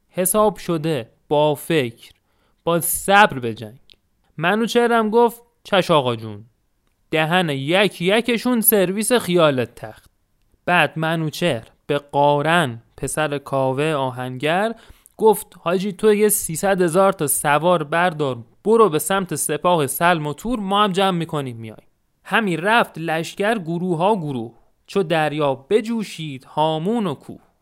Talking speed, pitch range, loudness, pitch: 125 wpm, 140-200 Hz, -19 LUFS, 165 Hz